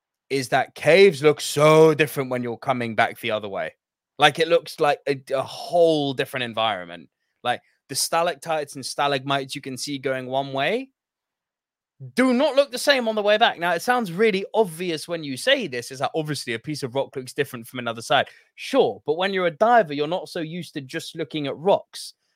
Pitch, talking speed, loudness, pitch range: 150 Hz, 210 wpm, -22 LUFS, 135-185 Hz